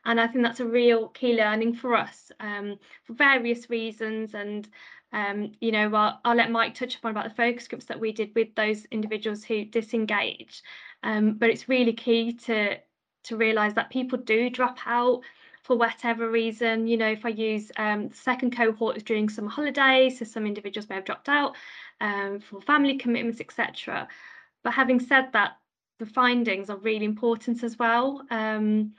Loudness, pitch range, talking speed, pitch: -25 LUFS, 215-240 Hz, 185 wpm, 230 Hz